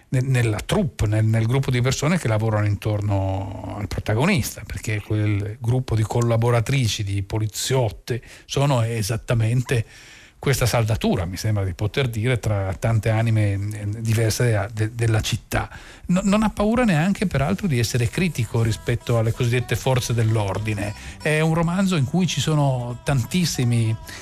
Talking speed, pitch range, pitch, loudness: 140 wpm, 110-130 Hz, 115 Hz, -22 LUFS